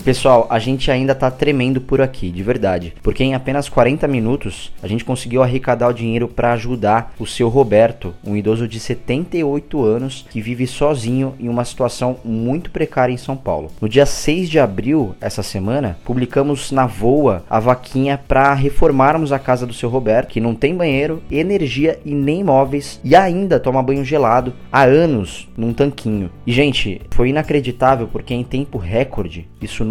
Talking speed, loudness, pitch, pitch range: 175 wpm, -17 LUFS, 130 Hz, 115-140 Hz